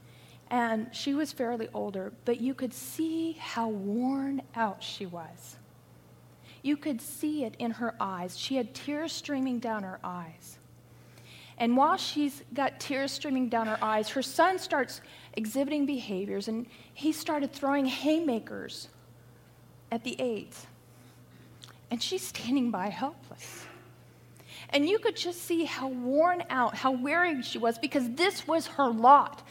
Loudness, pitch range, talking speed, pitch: -30 LUFS, 220-290 Hz, 145 wpm, 255 Hz